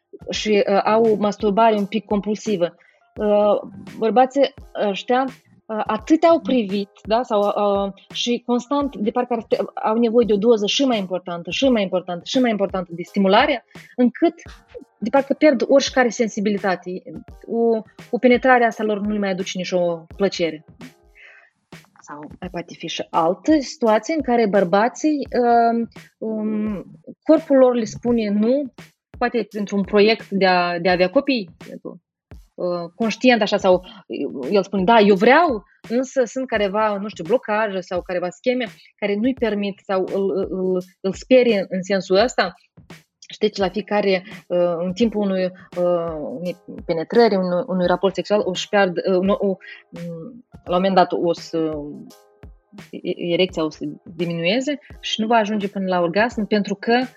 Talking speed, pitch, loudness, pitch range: 155 wpm, 205 Hz, -20 LUFS, 185-235 Hz